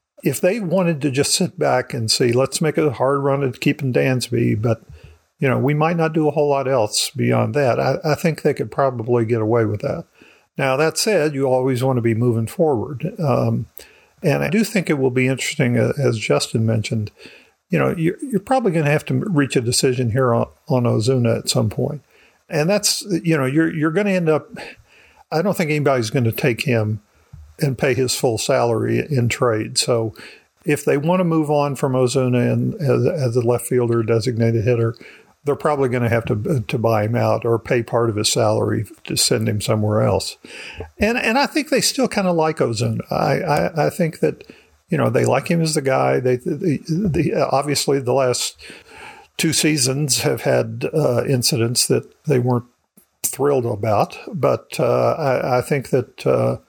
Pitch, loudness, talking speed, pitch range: 130 Hz, -19 LUFS, 205 wpm, 115-155 Hz